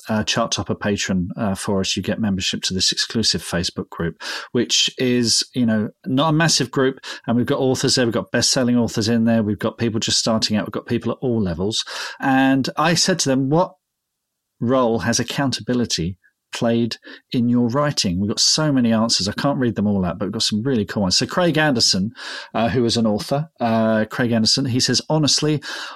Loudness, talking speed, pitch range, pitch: -19 LUFS, 215 wpm, 110-135 Hz, 115 Hz